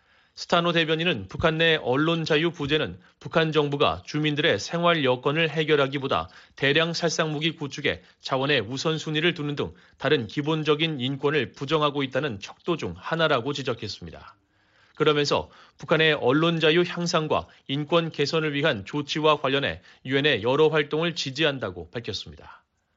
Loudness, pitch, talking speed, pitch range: -24 LUFS, 150 Hz, 340 characters per minute, 140-160 Hz